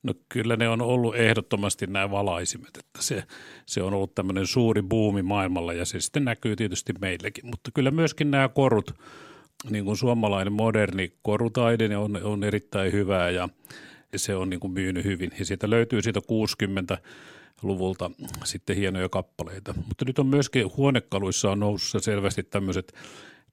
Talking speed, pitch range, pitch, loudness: 155 wpm, 95-115 Hz, 100 Hz, -26 LUFS